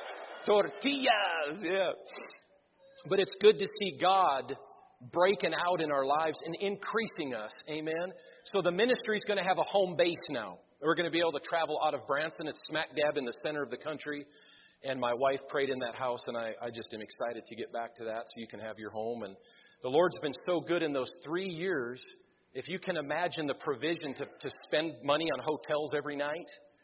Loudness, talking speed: -33 LUFS, 210 wpm